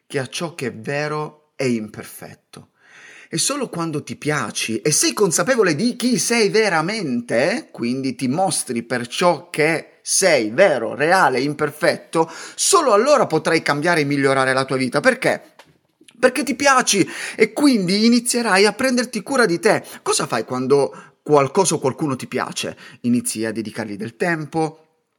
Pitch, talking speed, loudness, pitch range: 160 Hz, 150 wpm, -19 LUFS, 135-215 Hz